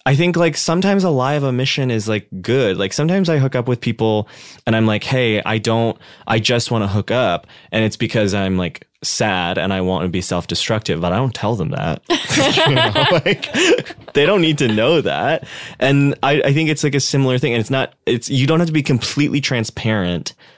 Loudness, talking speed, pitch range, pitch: -17 LUFS, 230 wpm, 110-145 Hz, 125 Hz